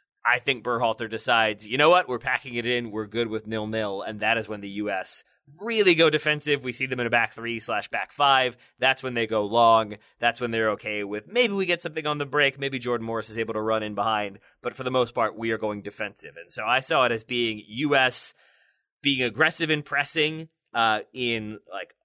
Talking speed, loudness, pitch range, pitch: 230 wpm, -24 LUFS, 110-140 Hz, 120 Hz